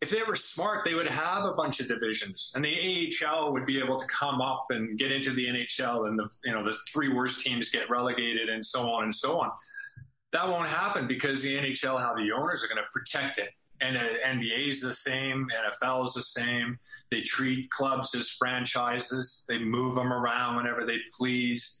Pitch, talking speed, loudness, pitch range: 130 Hz, 210 wpm, -29 LUFS, 120-135 Hz